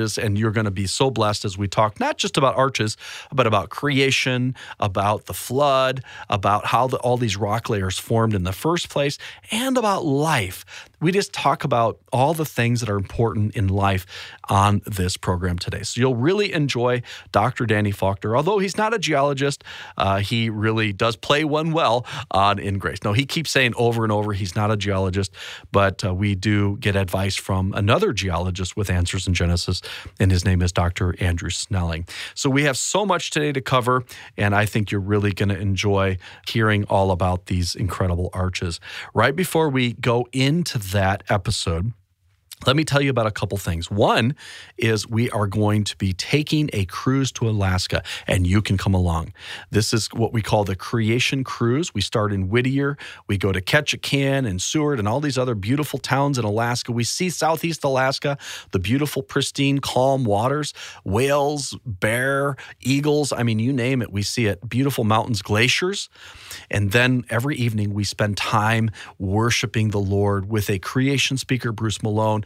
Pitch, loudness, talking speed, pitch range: 110 Hz, -21 LUFS, 185 wpm, 100-135 Hz